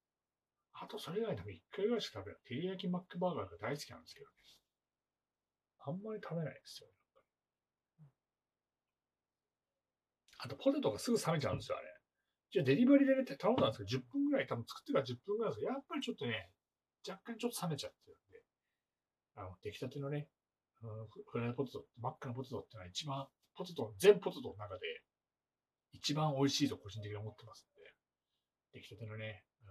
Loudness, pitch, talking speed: -38 LUFS, 145 Hz, 380 characters per minute